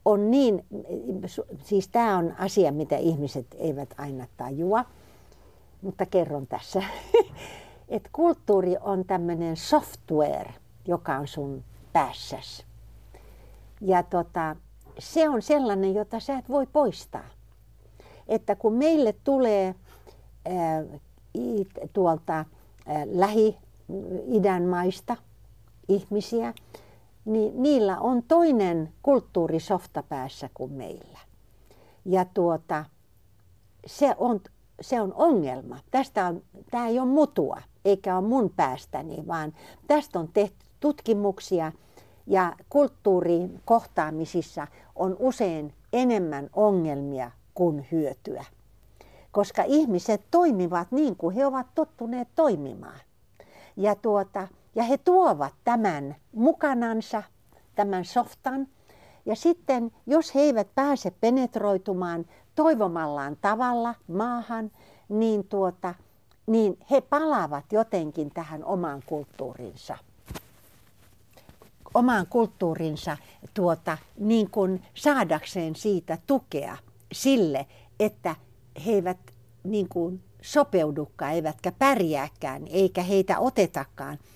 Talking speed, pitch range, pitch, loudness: 95 wpm, 155-230 Hz, 190 Hz, -26 LUFS